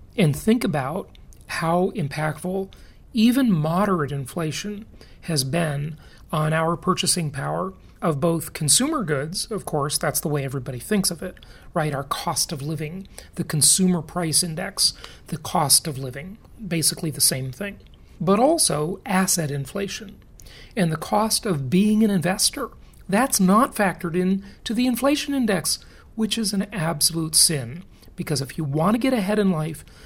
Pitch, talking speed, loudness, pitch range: 175 Hz, 155 wpm, -22 LUFS, 155-200 Hz